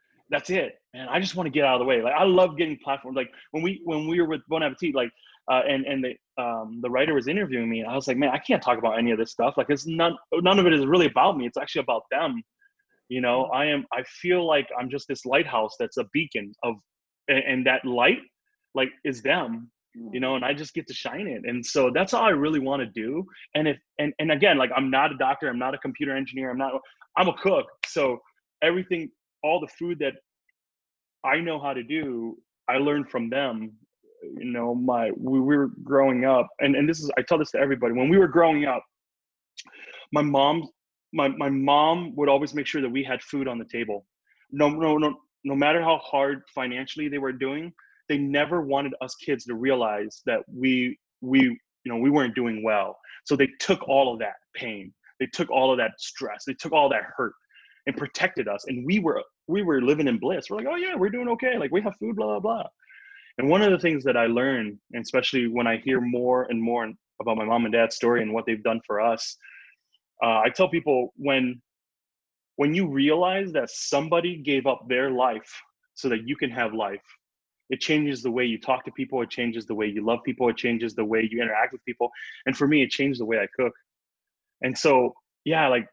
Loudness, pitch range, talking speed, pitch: -25 LUFS, 120-155 Hz, 230 wpm, 135 Hz